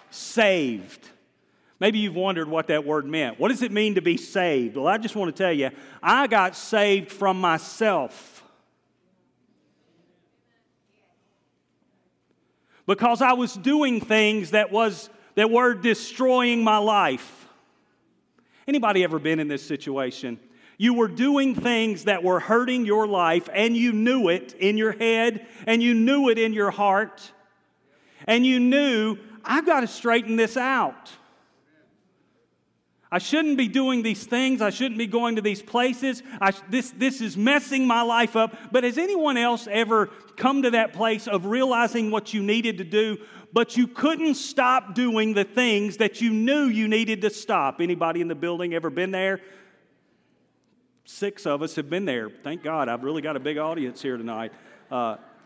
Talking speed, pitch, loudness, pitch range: 165 wpm, 220 Hz, -23 LUFS, 190-240 Hz